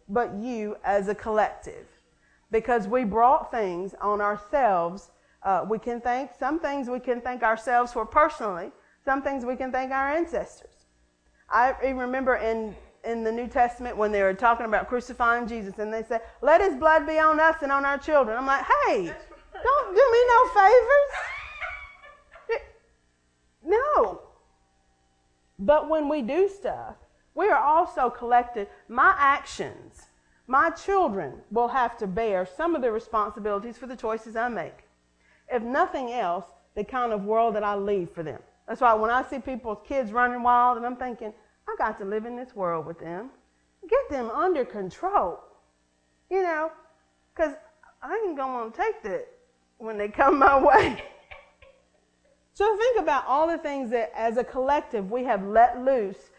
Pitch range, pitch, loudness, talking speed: 210-290 Hz, 245 Hz, -25 LUFS, 165 wpm